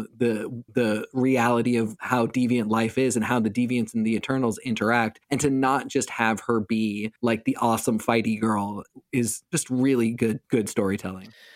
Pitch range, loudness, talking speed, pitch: 110-125 Hz, -24 LUFS, 175 wpm, 115 Hz